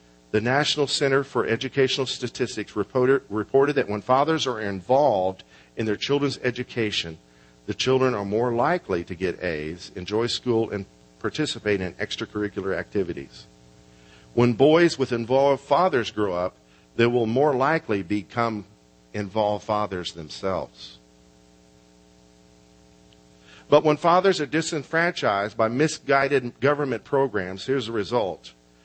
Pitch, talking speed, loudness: 110 Hz, 120 wpm, -24 LUFS